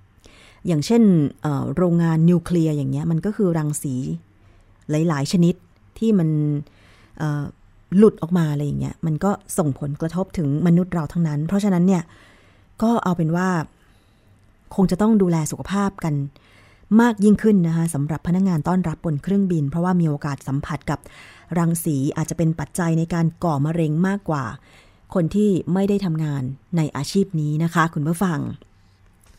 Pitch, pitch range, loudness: 160 Hz, 140-180 Hz, -21 LUFS